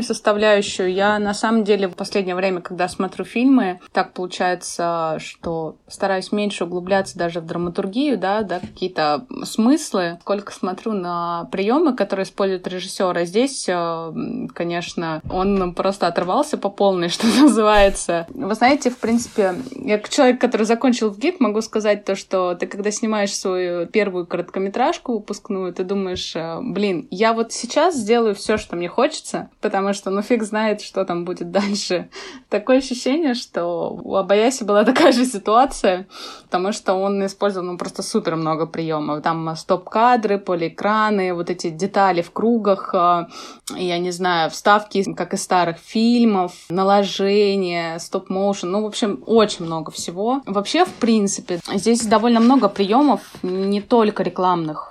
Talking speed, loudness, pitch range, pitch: 150 wpm, -20 LUFS, 180-220 Hz, 200 Hz